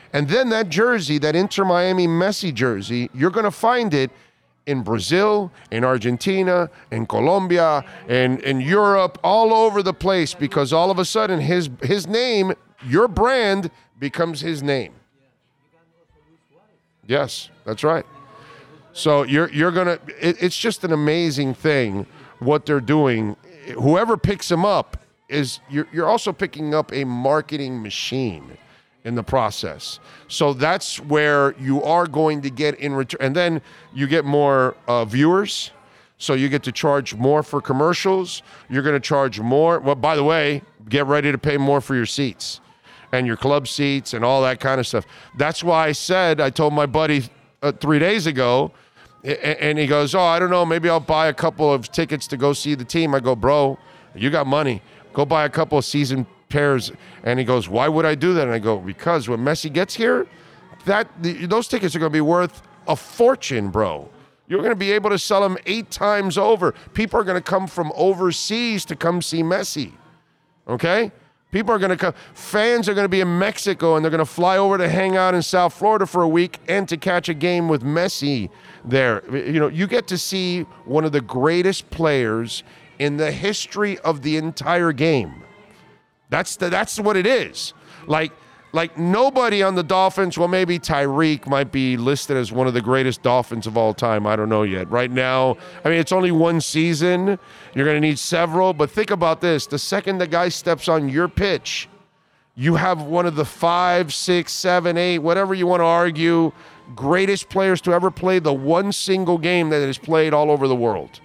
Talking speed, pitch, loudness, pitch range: 195 wpm, 160 Hz, -19 LUFS, 140-180 Hz